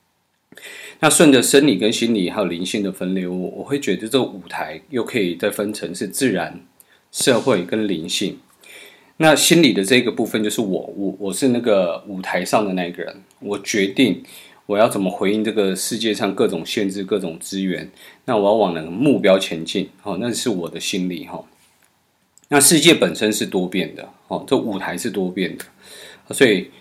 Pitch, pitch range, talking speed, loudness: 100 Hz, 95-110 Hz, 275 characters per minute, -19 LUFS